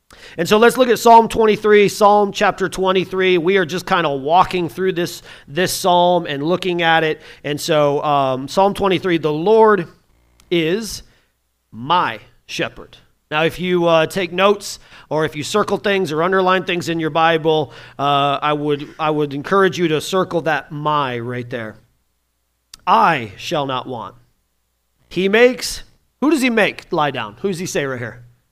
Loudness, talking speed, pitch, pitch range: -17 LUFS, 170 wpm, 165 Hz, 140-190 Hz